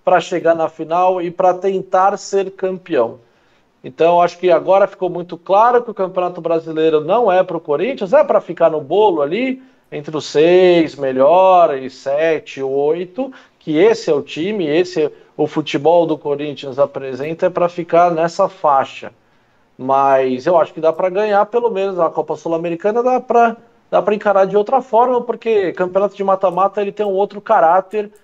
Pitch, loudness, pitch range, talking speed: 185 Hz, -15 LUFS, 165-205 Hz, 175 wpm